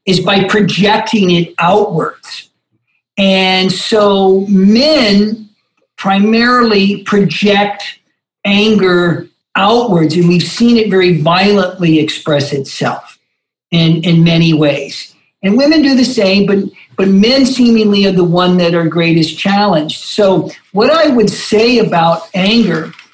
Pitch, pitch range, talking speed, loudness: 195 Hz, 170-210 Hz, 120 wpm, -10 LUFS